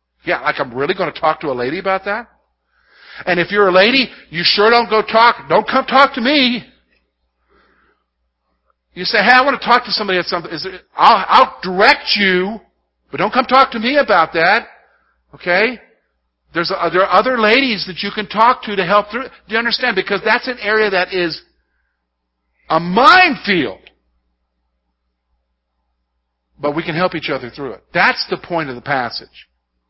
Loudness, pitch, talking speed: -14 LUFS, 185 Hz, 190 wpm